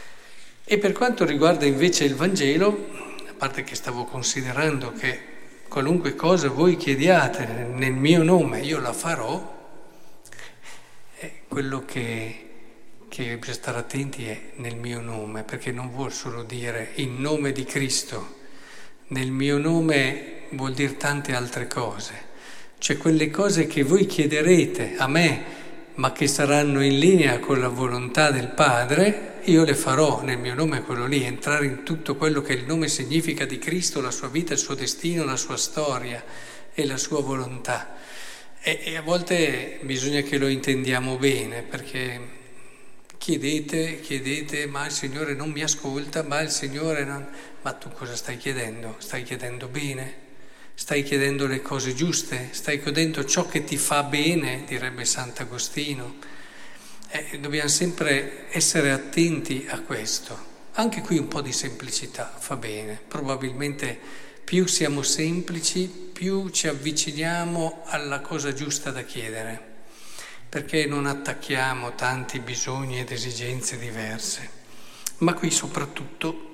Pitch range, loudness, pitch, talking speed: 130-160 Hz, -24 LUFS, 140 Hz, 140 wpm